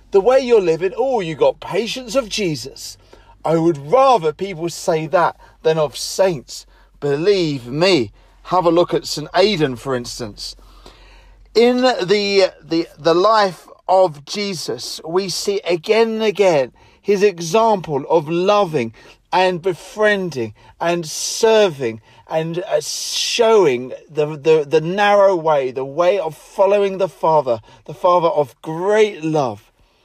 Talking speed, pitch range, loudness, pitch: 135 wpm, 150-205 Hz, -17 LUFS, 180 Hz